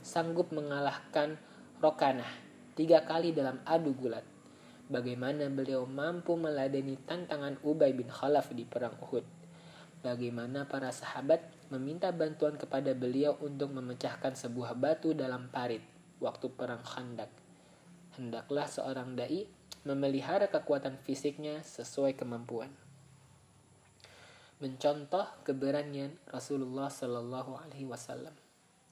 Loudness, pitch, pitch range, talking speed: -35 LUFS, 140 Hz, 130-155 Hz, 100 wpm